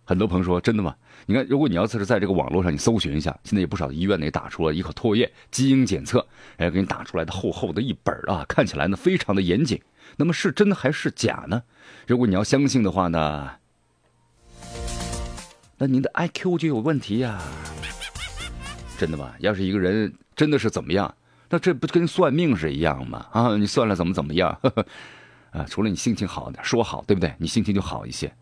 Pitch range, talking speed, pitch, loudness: 85-135 Hz, 320 characters per minute, 105 Hz, -23 LUFS